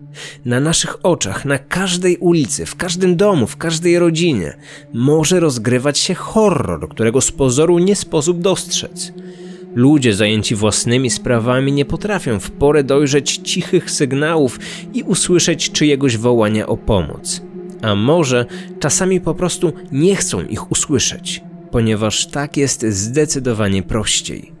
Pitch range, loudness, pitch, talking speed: 130-180 Hz, -15 LUFS, 155 Hz, 130 wpm